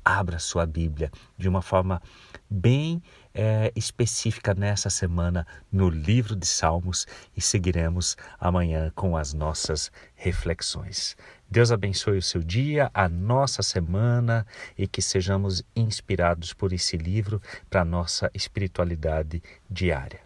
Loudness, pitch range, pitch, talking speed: -26 LUFS, 85-105 Hz, 95 Hz, 125 wpm